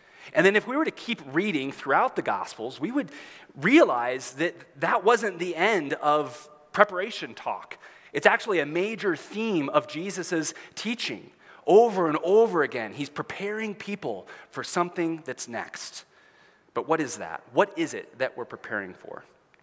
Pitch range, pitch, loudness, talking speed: 160-220 Hz, 180 Hz, -26 LUFS, 160 wpm